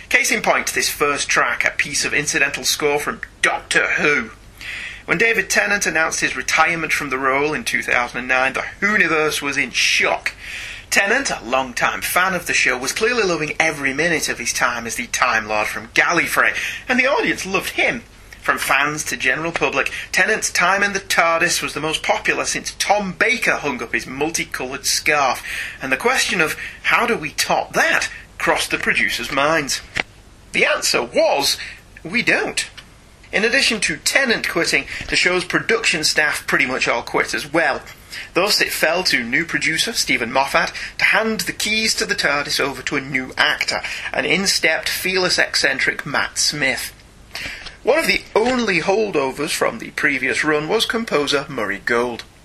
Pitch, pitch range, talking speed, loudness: 155 Hz, 135-185 Hz, 175 wpm, -18 LUFS